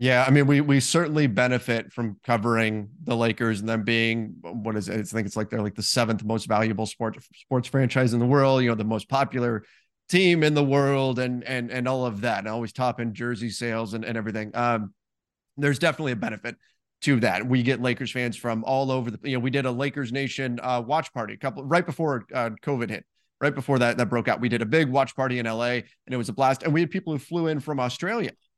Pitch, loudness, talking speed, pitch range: 125 Hz, -25 LUFS, 250 wpm, 115-135 Hz